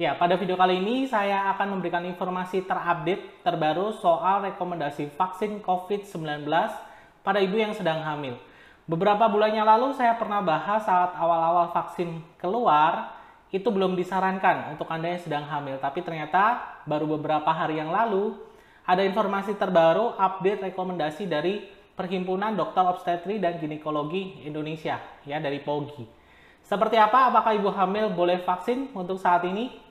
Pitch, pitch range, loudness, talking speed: 185 Hz, 165-205 Hz, -25 LUFS, 140 wpm